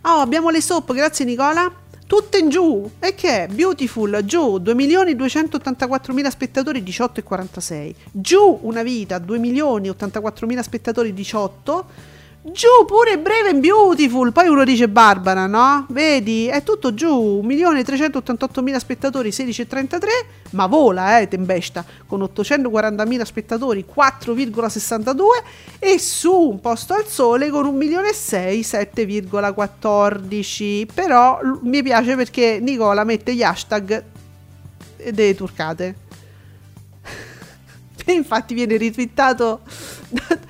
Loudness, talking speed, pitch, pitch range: -17 LUFS, 115 wpm, 245 Hz, 205-290 Hz